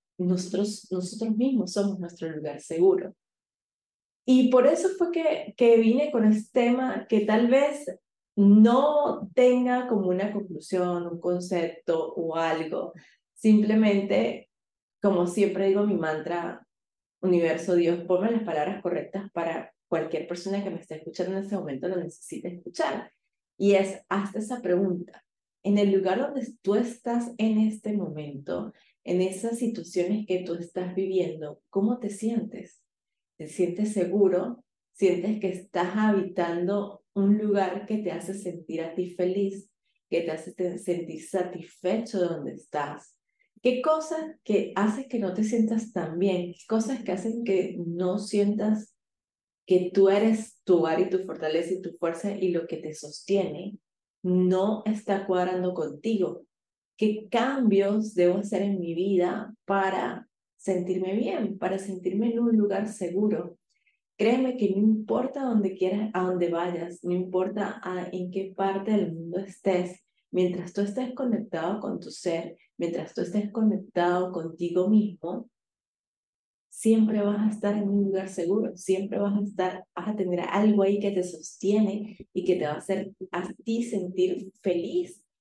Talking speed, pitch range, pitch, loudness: 150 wpm, 180-215 Hz, 195 Hz, -27 LUFS